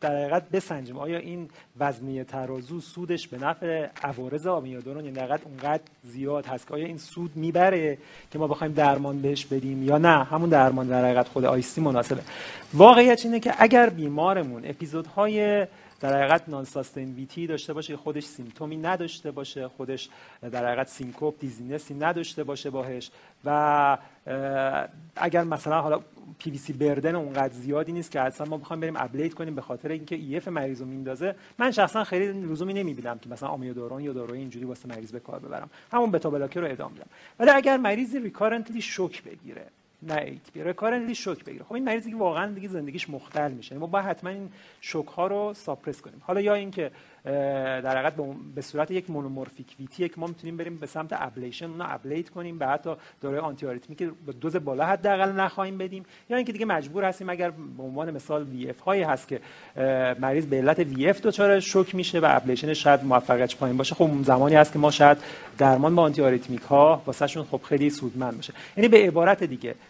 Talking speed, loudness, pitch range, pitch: 190 wpm, -25 LUFS, 135-175 Hz, 150 Hz